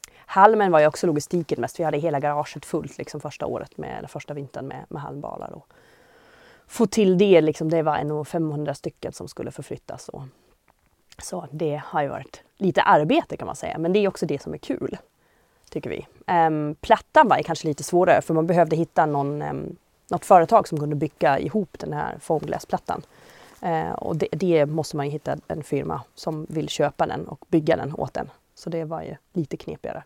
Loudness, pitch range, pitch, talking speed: -23 LUFS, 150-180 Hz, 160 Hz, 200 wpm